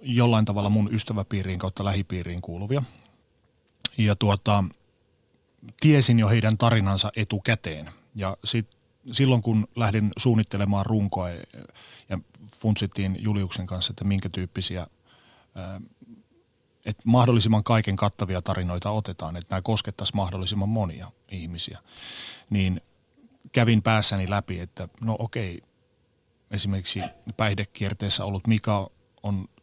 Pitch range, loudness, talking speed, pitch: 95-110 Hz, -25 LUFS, 105 wpm, 105 Hz